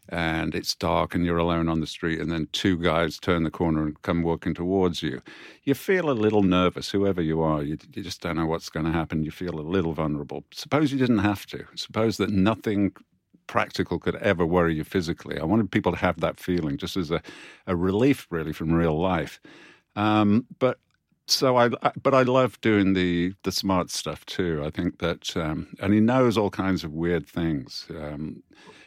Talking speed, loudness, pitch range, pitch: 210 wpm, -25 LUFS, 80-105 Hz, 90 Hz